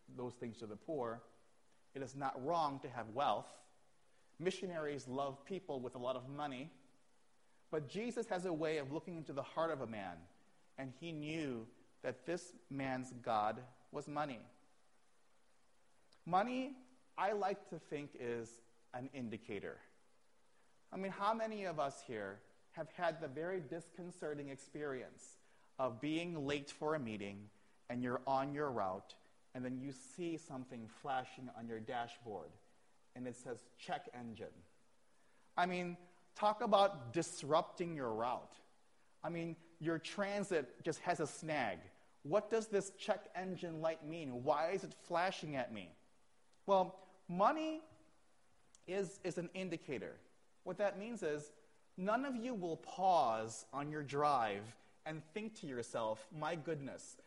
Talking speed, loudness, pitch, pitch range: 145 wpm, -42 LUFS, 155 Hz, 130-180 Hz